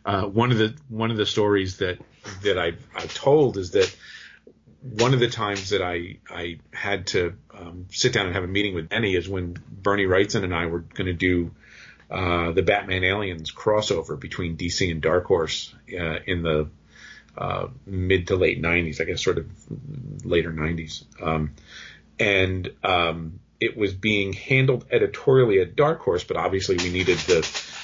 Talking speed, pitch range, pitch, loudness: 180 wpm, 85-110 Hz, 95 Hz, -23 LUFS